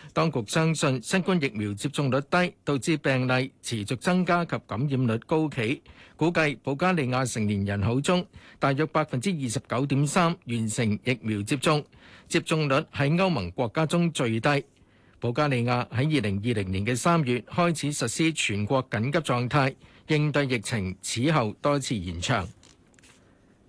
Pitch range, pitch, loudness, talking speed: 115-155 Hz, 135 Hz, -26 LUFS, 245 characters per minute